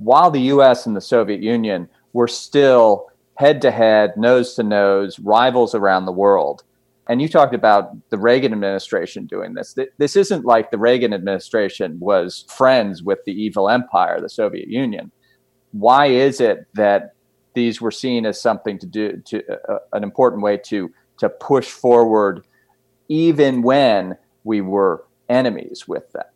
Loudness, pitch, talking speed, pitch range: -17 LUFS, 120 Hz, 160 wpm, 105-130 Hz